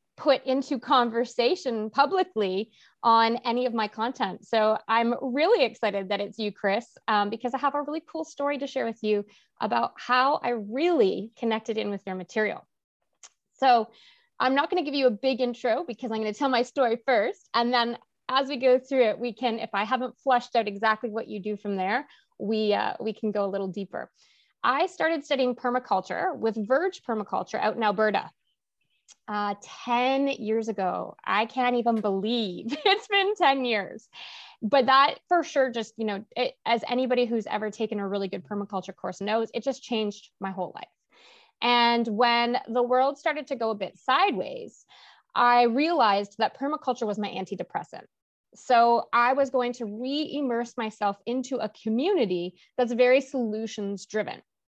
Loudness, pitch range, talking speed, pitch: -26 LUFS, 215-265 Hz, 180 wpm, 235 Hz